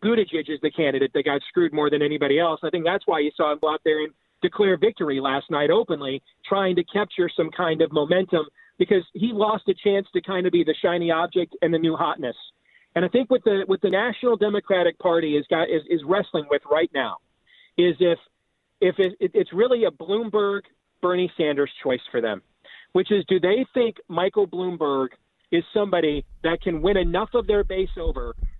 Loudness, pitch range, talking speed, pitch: -23 LUFS, 155-195 Hz, 205 wpm, 175 Hz